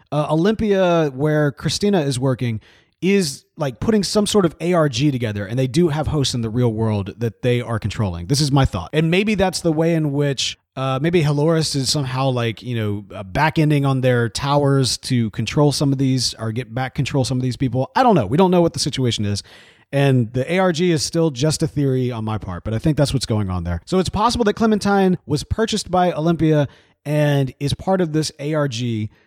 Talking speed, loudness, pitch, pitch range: 220 wpm, -19 LUFS, 140 Hz, 120-165 Hz